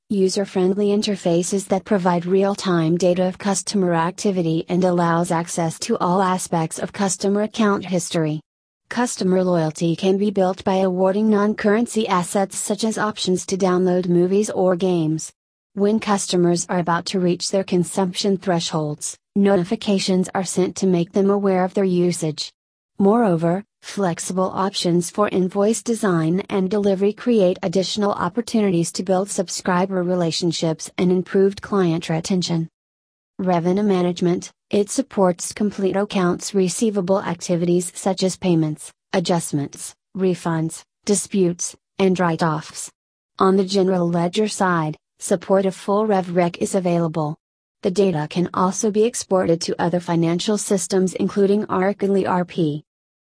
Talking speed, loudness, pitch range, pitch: 125 wpm, -20 LUFS, 175-200 Hz, 185 Hz